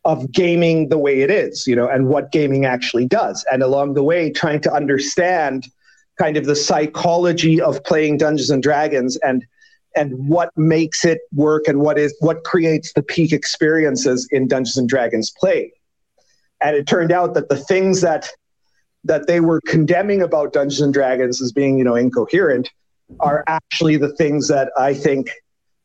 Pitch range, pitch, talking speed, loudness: 140-165 Hz, 150 Hz, 175 wpm, -17 LUFS